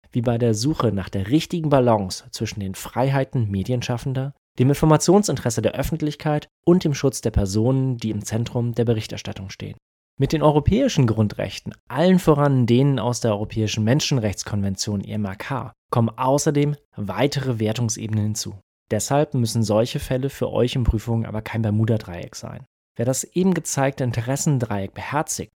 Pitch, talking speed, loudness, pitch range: 120 Hz, 145 wpm, -22 LUFS, 110-140 Hz